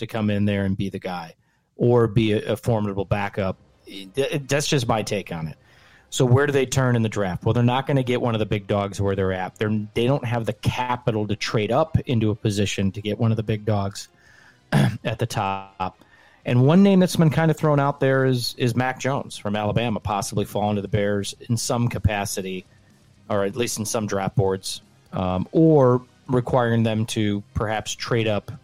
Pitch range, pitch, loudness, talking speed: 105-125 Hz, 110 Hz, -22 LUFS, 215 wpm